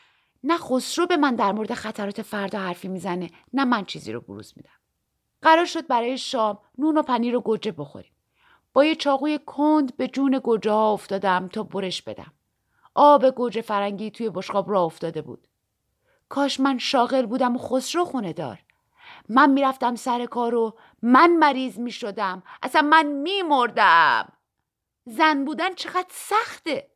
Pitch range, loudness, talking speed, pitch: 215-295 Hz, -22 LUFS, 150 wpm, 250 Hz